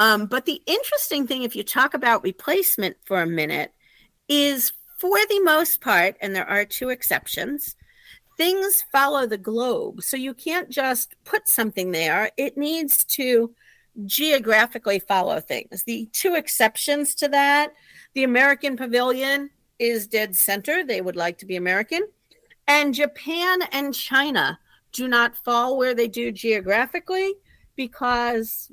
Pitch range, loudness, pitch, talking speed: 225-295 Hz, -21 LUFS, 260 Hz, 145 wpm